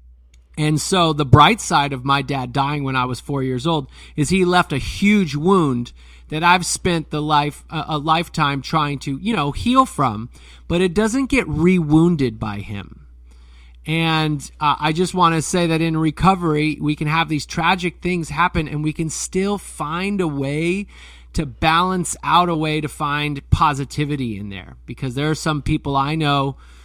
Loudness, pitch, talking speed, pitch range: -19 LUFS, 150 Hz, 185 wpm, 135-170 Hz